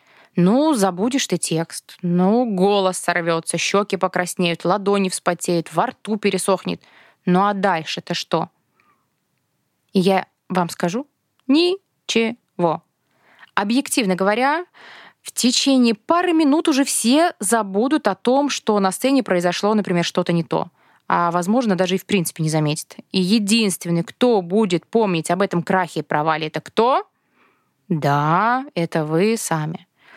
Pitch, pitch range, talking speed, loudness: 190 Hz, 175-230 Hz, 130 wpm, -19 LUFS